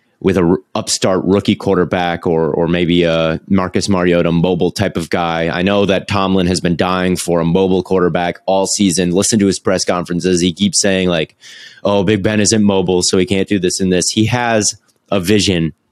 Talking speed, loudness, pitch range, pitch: 205 wpm, -14 LUFS, 90-100 Hz, 95 Hz